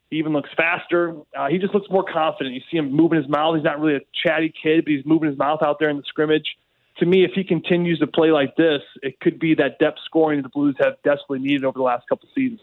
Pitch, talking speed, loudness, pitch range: 155 Hz, 275 wpm, -20 LUFS, 145-165 Hz